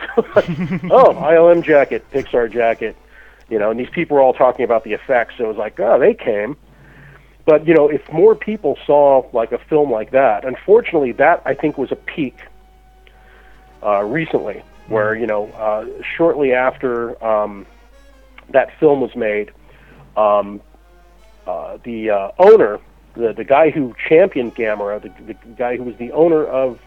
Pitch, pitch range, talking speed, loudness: 135 Hz, 110-170 Hz, 170 wpm, -16 LUFS